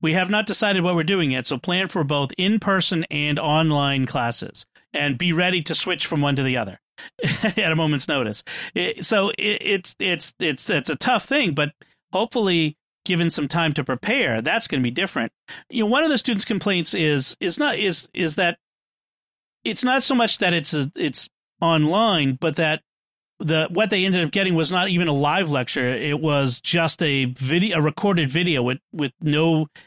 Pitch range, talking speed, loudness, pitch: 145-195 Hz, 200 wpm, -21 LUFS, 165 Hz